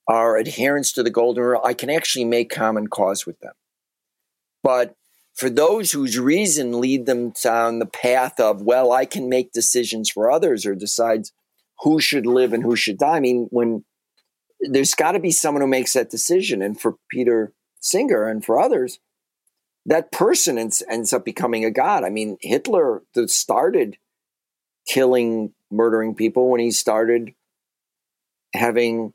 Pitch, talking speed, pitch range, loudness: 120 Hz, 165 wpm, 110-125 Hz, -19 LUFS